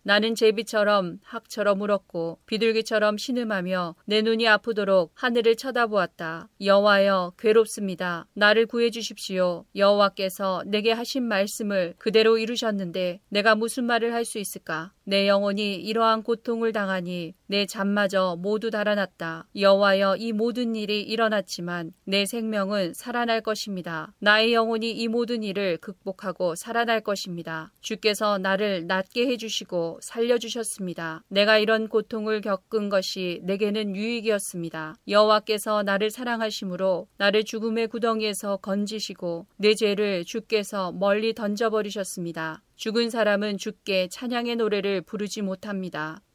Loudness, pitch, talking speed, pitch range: -25 LUFS, 205 Hz, 330 characters per minute, 190-225 Hz